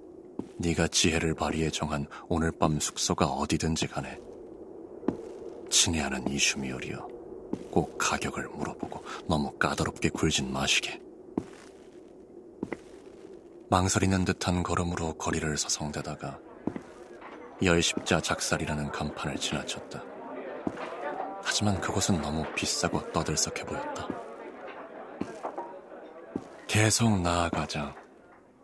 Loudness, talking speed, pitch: -29 LUFS, 225 characters per minute, 90 Hz